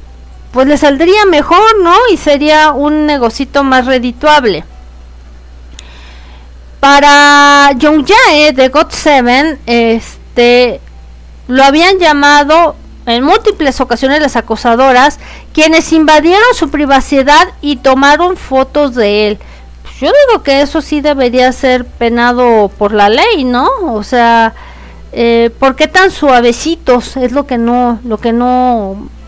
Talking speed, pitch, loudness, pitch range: 125 wpm, 265 Hz, -7 LUFS, 235-300 Hz